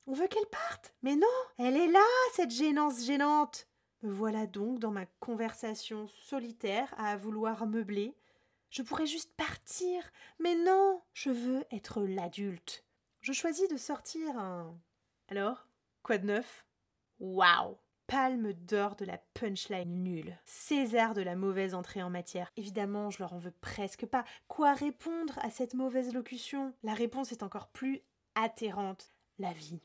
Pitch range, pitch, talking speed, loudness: 205-290 Hz, 230 Hz, 155 wpm, -34 LUFS